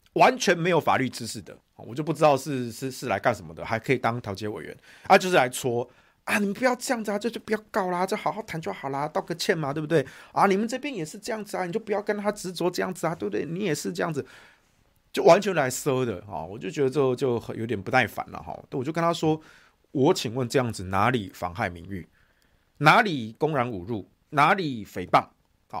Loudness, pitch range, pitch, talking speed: -26 LUFS, 120-195 Hz, 155 Hz, 340 characters per minute